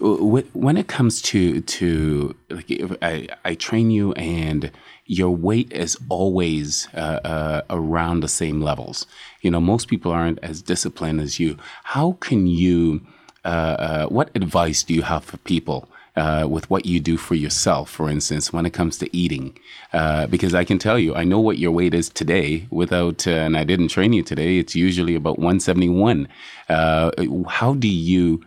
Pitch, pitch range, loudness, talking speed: 85 Hz, 80-90 Hz, -20 LUFS, 180 wpm